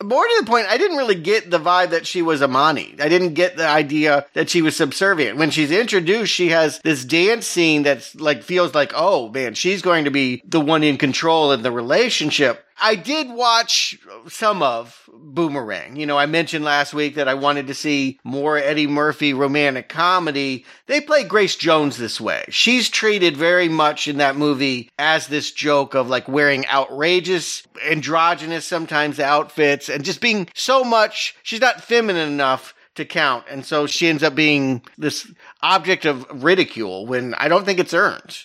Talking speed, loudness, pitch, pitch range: 185 wpm, -18 LUFS, 155 Hz, 145-180 Hz